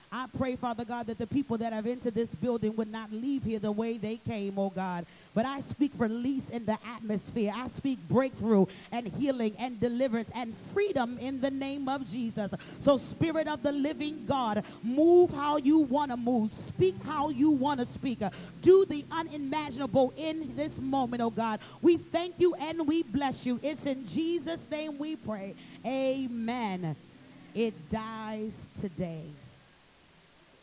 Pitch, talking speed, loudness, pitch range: 245 Hz, 170 wpm, -31 LUFS, 220-285 Hz